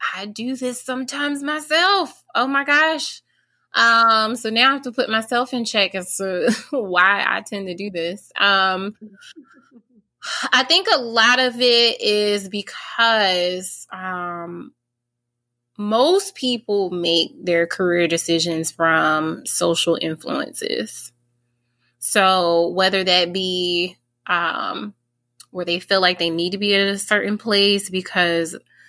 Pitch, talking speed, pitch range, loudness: 195 Hz, 130 wpm, 170-235 Hz, -18 LUFS